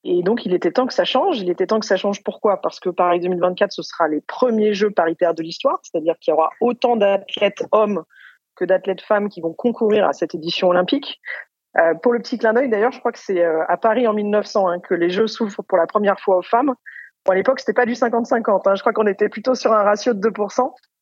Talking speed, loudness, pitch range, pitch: 250 wpm, -19 LUFS, 180-235 Hz, 205 Hz